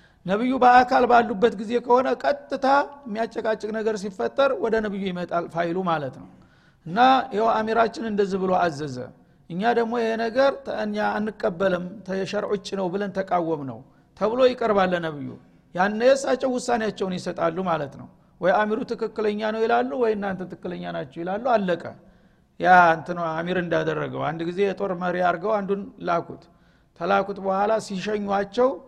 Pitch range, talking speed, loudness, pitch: 180-230 Hz, 135 wpm, -23 LUFS, 200 Hz